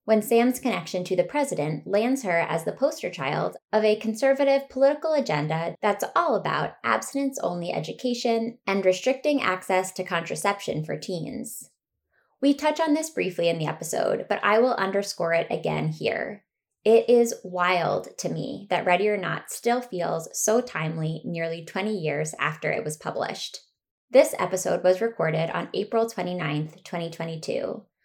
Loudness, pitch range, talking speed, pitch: -25 LUFS, 165-235 Hz, 155 wpm, 190 Hz